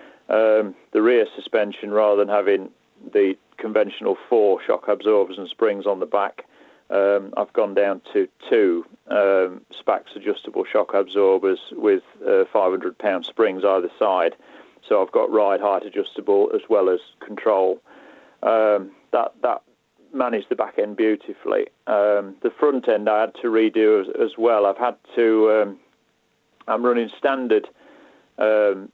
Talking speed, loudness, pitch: 145 wpm, -21 LUFS, 145 Hz